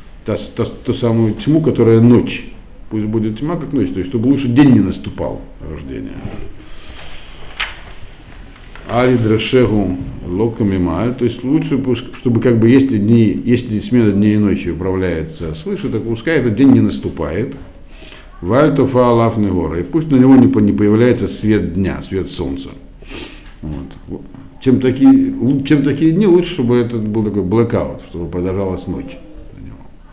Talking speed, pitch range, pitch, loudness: 135 wpm, 95-130 Hz, 115 Hz, -14 LUFS